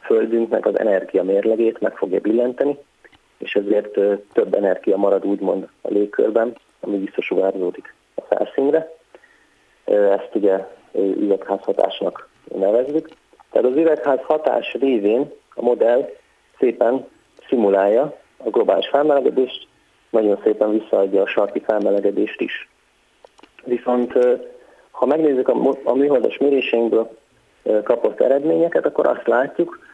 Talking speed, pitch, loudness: 105 wpm, 145 Hz, -19 LUFS